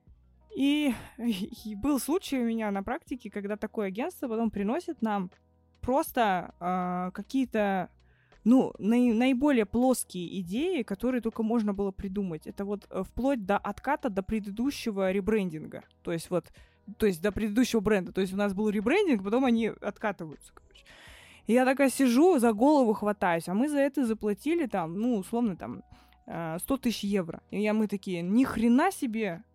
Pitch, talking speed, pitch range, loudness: 220 Hz, 160 wpm, 200-255 Hz, -29 LUFS